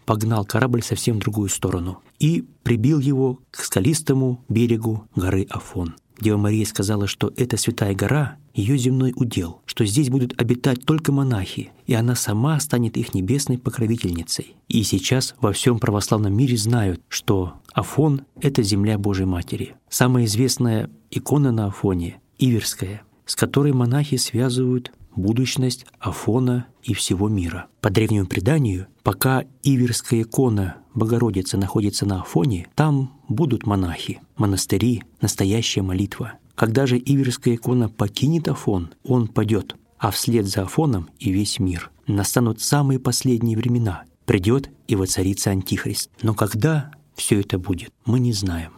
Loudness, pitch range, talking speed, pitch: -21 LUFS, 100-130 Hz, 140 wpm, 115 Hz